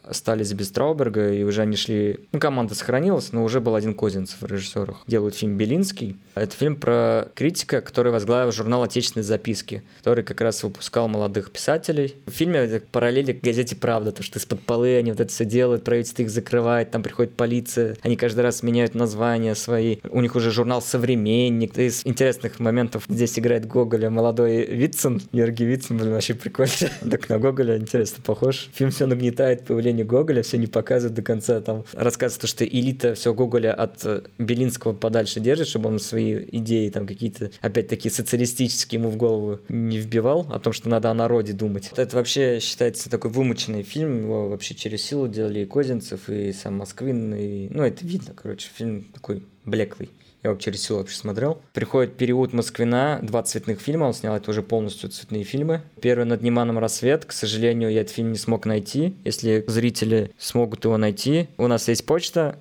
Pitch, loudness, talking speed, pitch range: 115 Hz, -23 LUFS, 185 wpm, 110-125 Hz